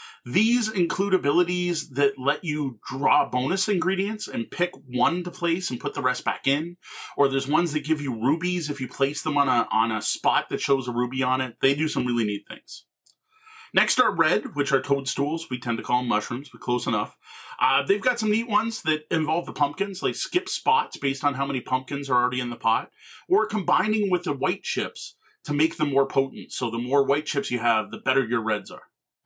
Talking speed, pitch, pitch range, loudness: 225 wpm, 140 Hz, 125-175 Hz, -25 LUFS